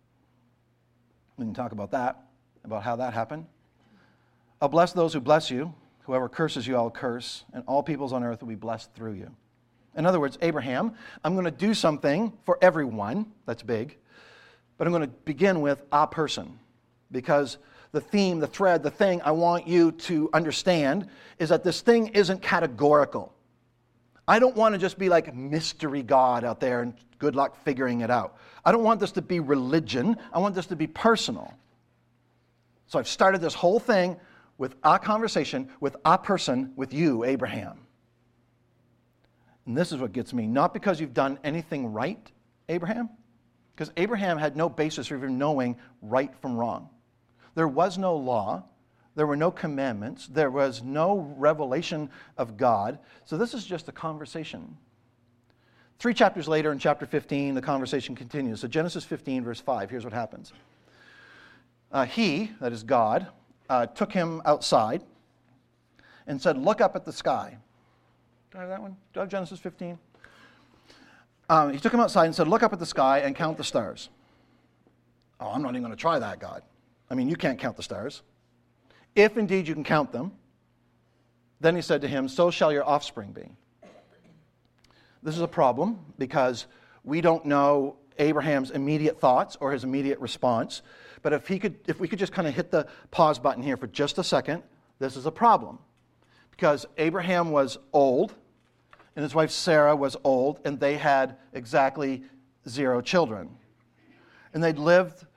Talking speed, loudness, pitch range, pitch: 175 wpm, -26 LUFS, 130-170 Hz, 150 Hz